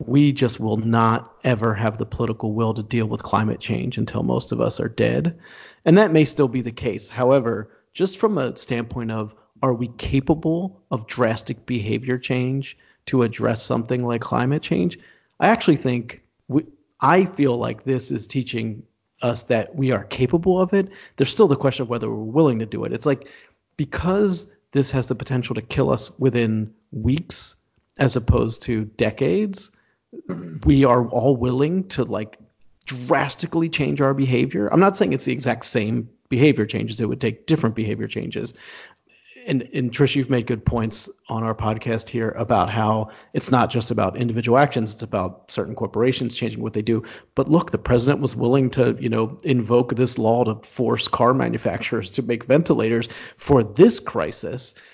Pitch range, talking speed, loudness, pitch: 115-140 Hz, 180 wpm, -21 LUFS, 125 Hz